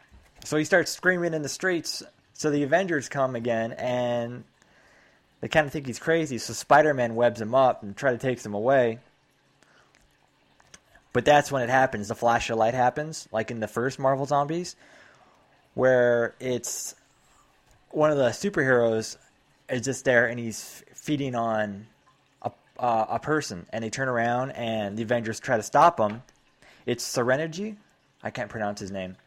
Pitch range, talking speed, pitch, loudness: 115-145 Hz, 165 wpm, 125 Hz, -25 LUFS